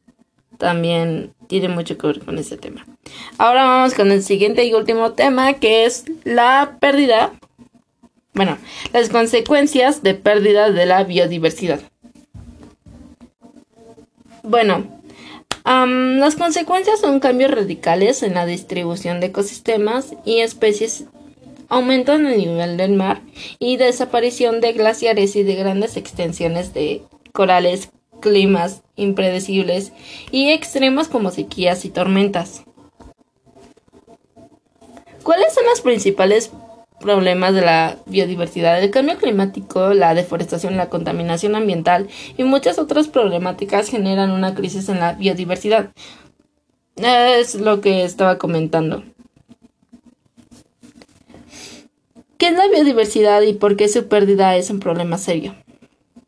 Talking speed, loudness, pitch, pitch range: 115 wpm, -16 LUFS, 210 Hz, 185-245 Hz